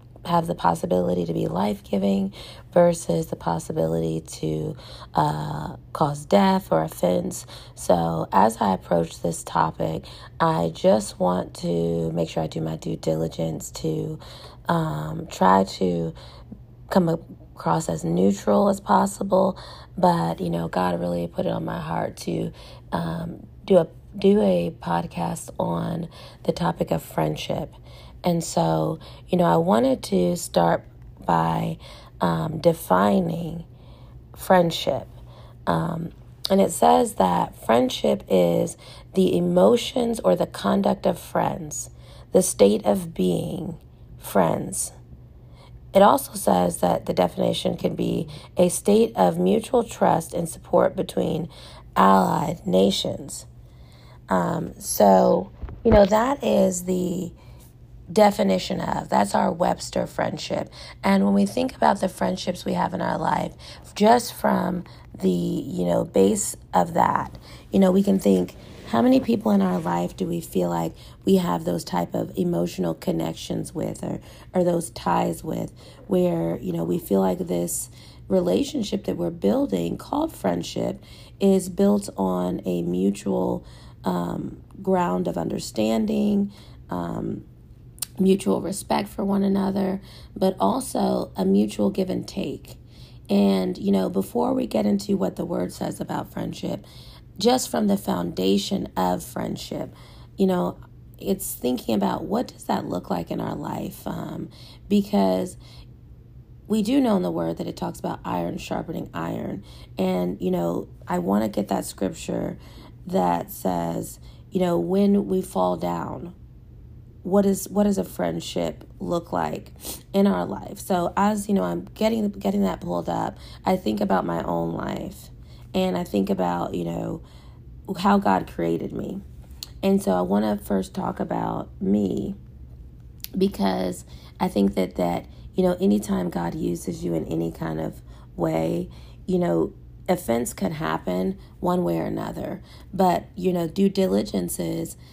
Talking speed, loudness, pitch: 145 wpm, -24 LUFS, 110 Hz